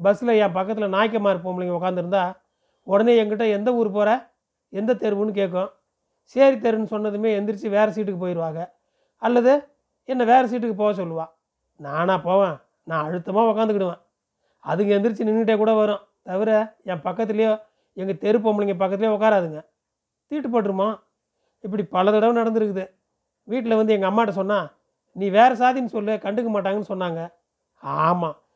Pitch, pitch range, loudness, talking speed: 210 Hz, 190-225 Hz, -22 LUFS, 135 wpm